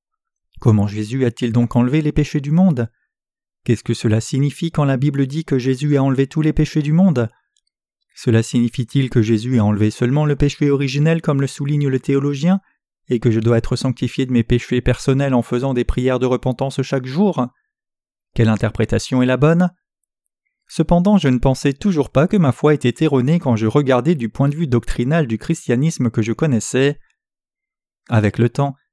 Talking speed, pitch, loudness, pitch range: 190 wpm, 135 Hz, -17 LUFS, 120-150 Hz